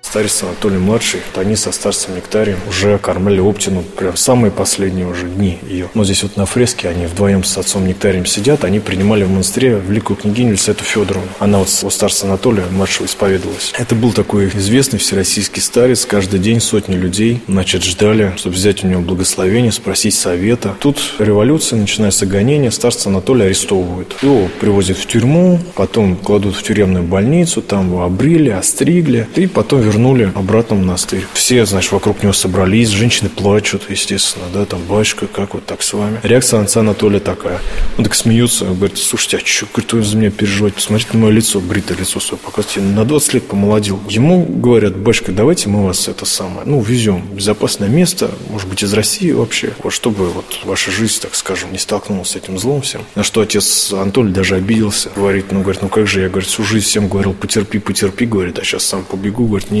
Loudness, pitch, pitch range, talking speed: -13 LUFS, 100 Hz, 95-110 Hz, 190 wpm